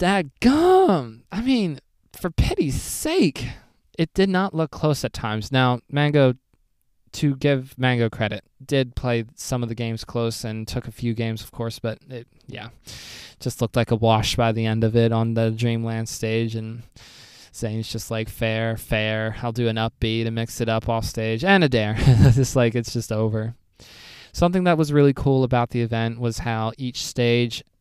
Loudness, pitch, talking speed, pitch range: -22 LUFS, 120 Hz, 190 wpm, 115-135 Hz